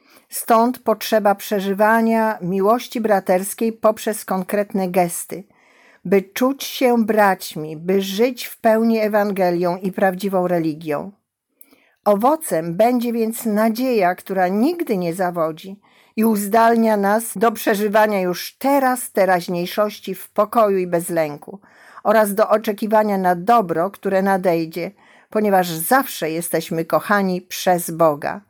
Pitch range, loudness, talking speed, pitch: 180-225 Hz, -19 LUFS, 115 wpm, 205 Hz